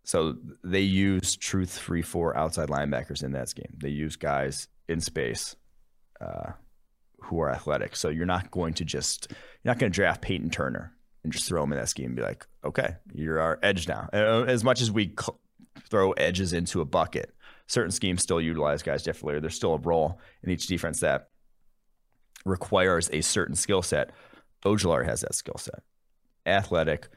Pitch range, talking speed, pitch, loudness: 75-95 Hz, 185 wpm, 85 Hz, -28 LUFS